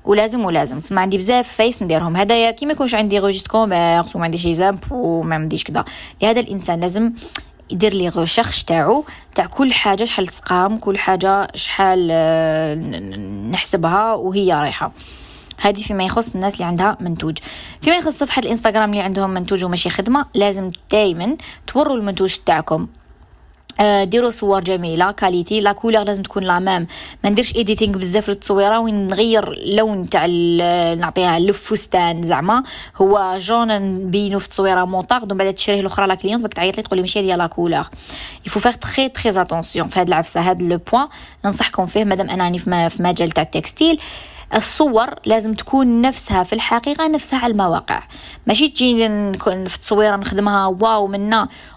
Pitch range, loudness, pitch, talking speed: 180-220 Hz, -17 LUFS, 200 Hz, 155 wpm